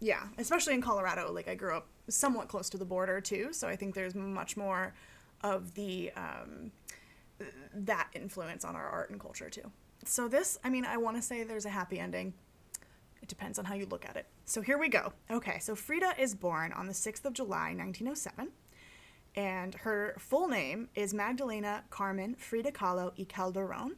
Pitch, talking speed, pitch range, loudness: 205 Hz, 200 wpm, 190-240 Hz, -36 LUFS